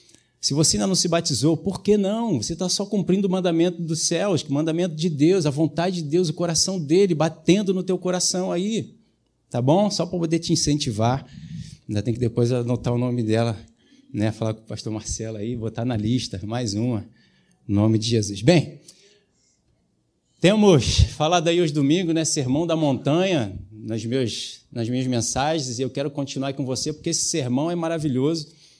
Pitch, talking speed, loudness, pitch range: 155 Hz, 190 wpm, -22 LUFS, 120-175 Hz